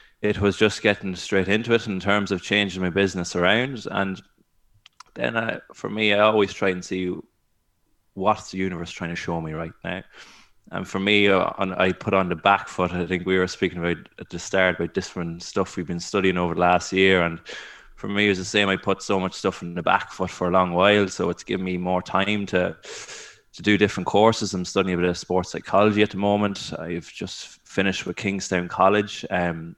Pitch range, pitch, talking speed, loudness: 90-100 Hz, 95 Hz, 225 wpm, -23 LUFS